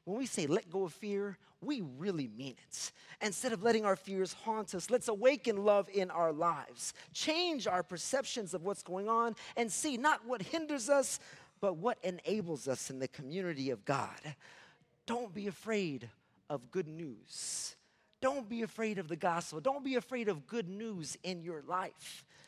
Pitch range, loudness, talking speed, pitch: 175-235 Hz, -37 LUFS, 180 wpm, 200 Hz